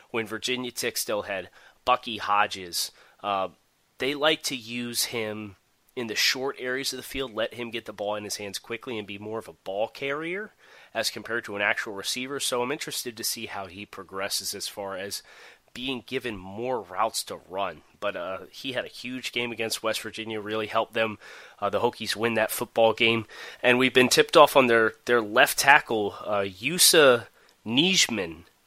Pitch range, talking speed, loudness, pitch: 110-130 Hz, 195 wpm, -25 LUFS, 115 Hz